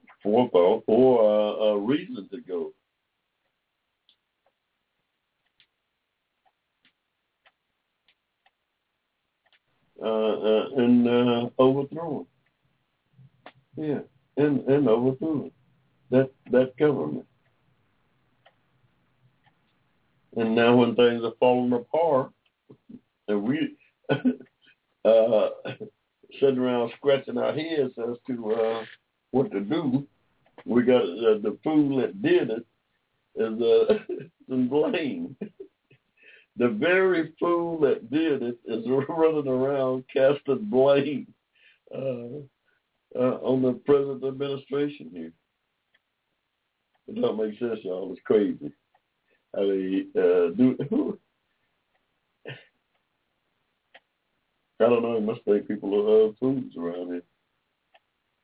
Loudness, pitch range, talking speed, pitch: -24 LUFS, 115-150 Hz, 100 wpm, 130 Hz